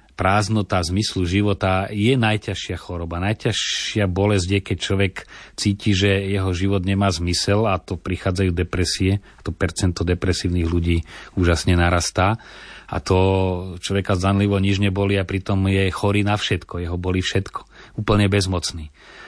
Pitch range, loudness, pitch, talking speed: 90-100 Hz, -21 LUFS, 95 Hz, 135 wpm